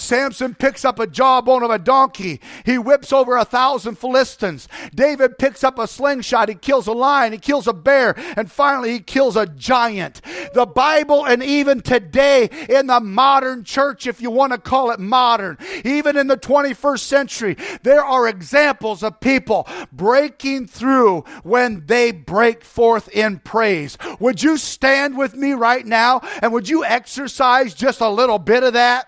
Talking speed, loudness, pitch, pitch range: 175 wpm, -16 LUFS, 255 Hz, 230-275 Hz